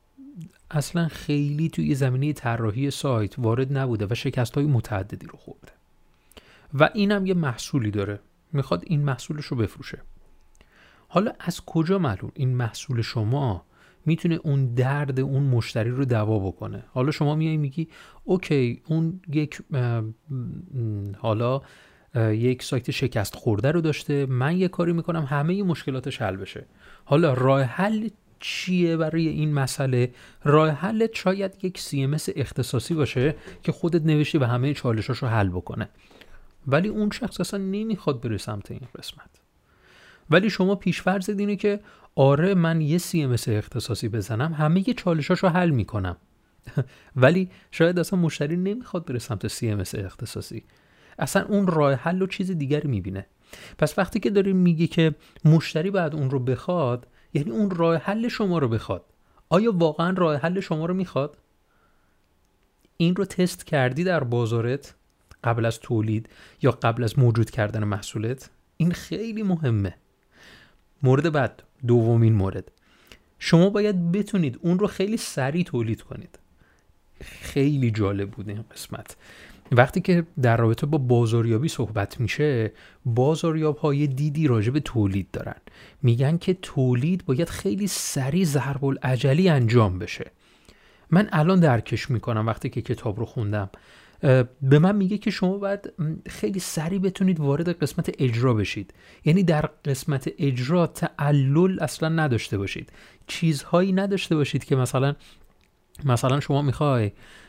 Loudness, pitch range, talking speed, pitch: -24 LUFS, 120-170 Hz, 140 wpm, 140 Hz